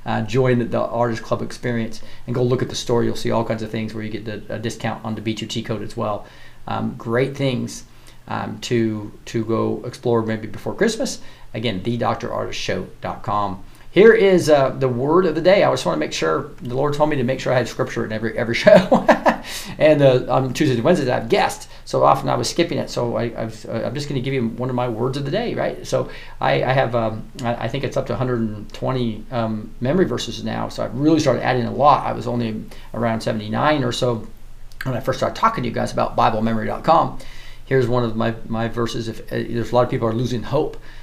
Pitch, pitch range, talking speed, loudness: 115 Hz, 110-125 Hz, 235 wpm, -20 LUFS